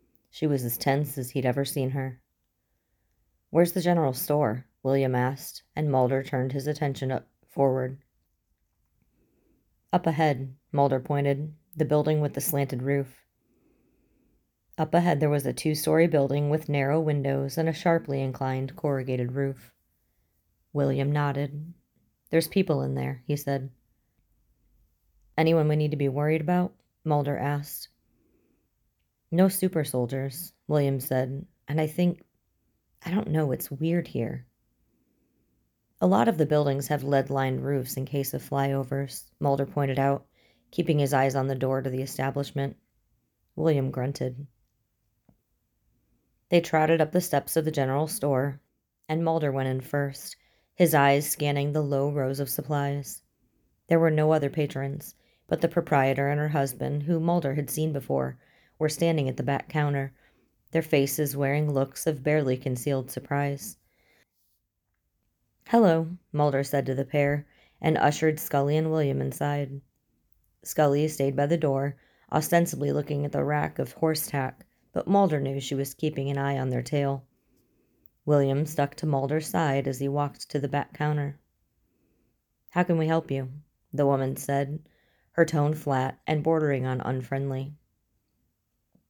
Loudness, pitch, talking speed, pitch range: -27 LUFS, 140 Hz, 150 wpm, 135-155 Hz